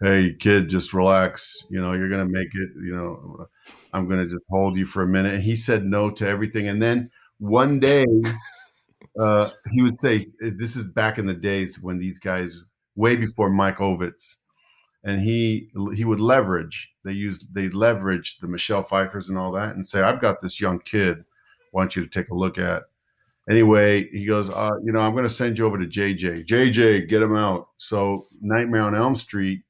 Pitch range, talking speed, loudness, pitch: 95-110 Hz, 200 wpm, -22 LUFS, 100 Hz